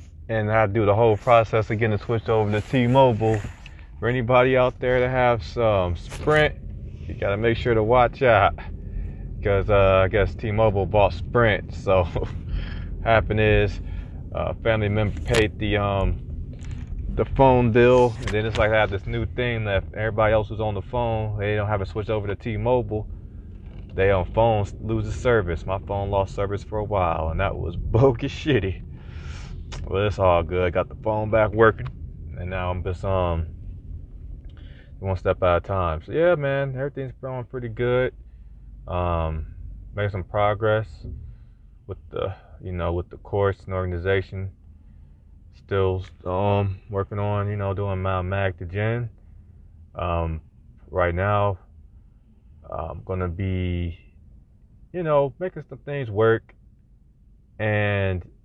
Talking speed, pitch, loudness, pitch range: 160 wpm, 100 Hz, -23 LUFS, 90-110 Hz